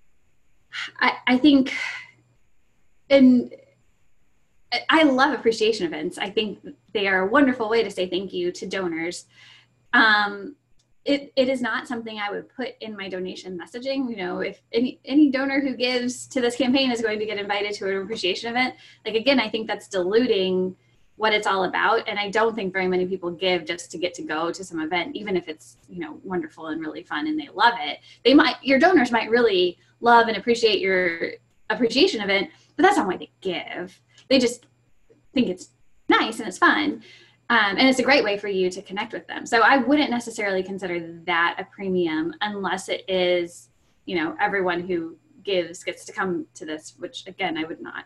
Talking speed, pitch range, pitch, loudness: 195 wpm, 180-255 Hz, 210 Hz, -22 LUFS